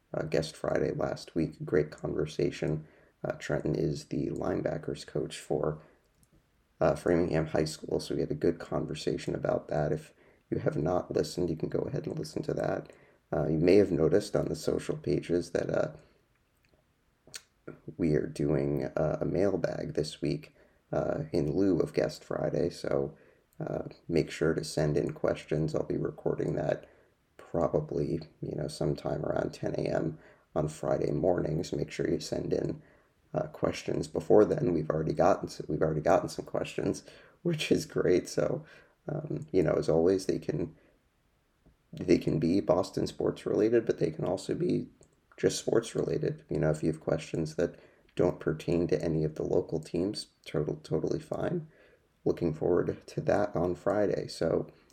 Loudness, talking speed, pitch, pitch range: -31 LUFS, 165 wpm, 80 Hz, 75-85 Hz